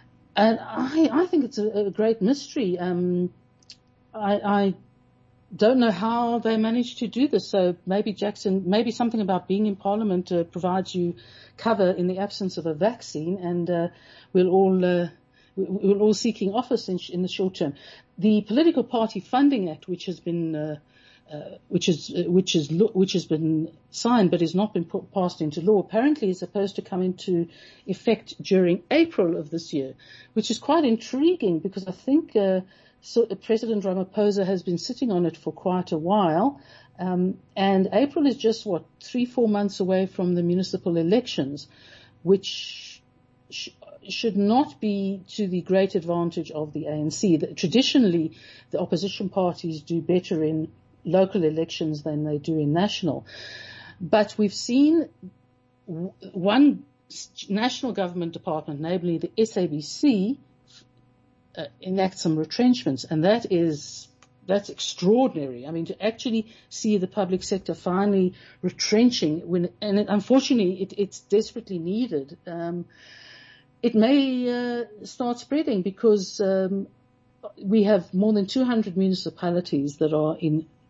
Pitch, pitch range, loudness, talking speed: 190 Hz, 170-215 Hz, -24 LUFS, 150 wpm